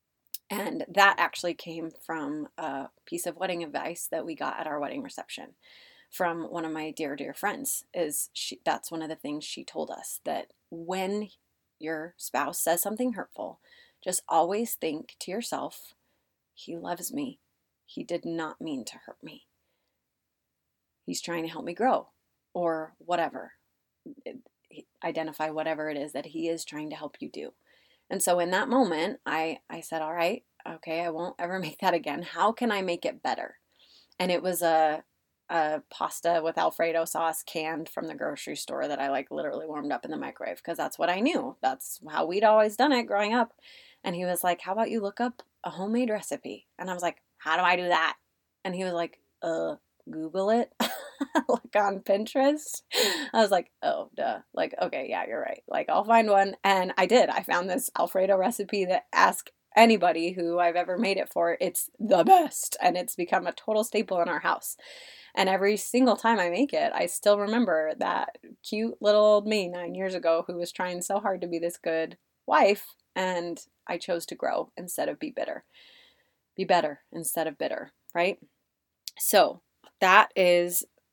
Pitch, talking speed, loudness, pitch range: 180 Hz, 190 wpm, -28 LUFS, 165-210 Hz